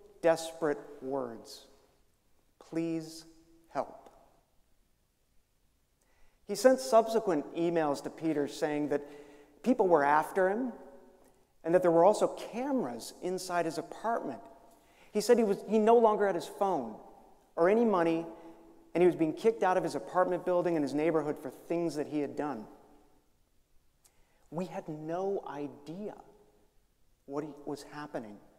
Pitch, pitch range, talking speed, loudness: 165 Hz, 145-185 Hz, 135 wpm, -31 LUFS